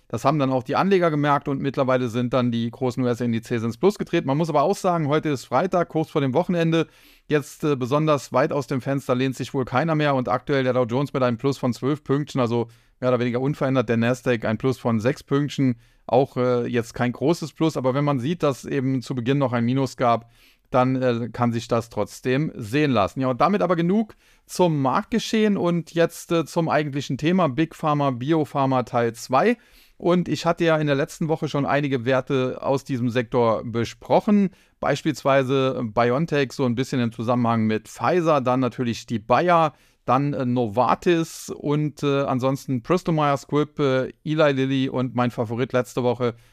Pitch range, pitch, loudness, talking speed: 125-150 Hz, 135 Hz, -22 LUFS, 195 wpm